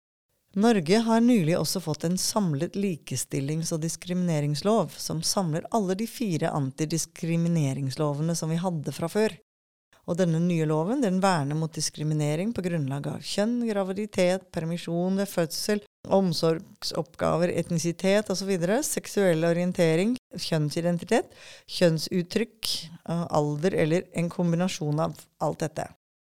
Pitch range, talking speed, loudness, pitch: 160-195 Hz, 115 wpm, -27 LUFS, 170 Hz